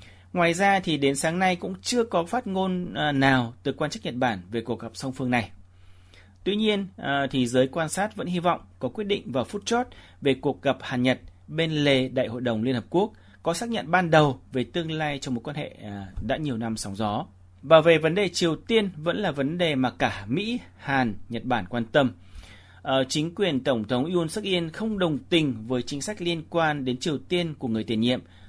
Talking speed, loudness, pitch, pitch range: 225 wpm, -25 LUFS, 140 Hz, 115-175 Hz